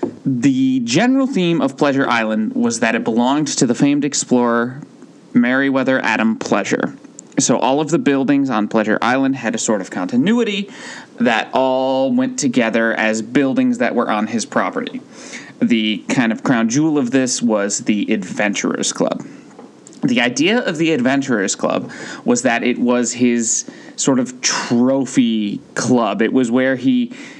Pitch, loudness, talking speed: 145 Hz, -17 LUFS, 155 wpm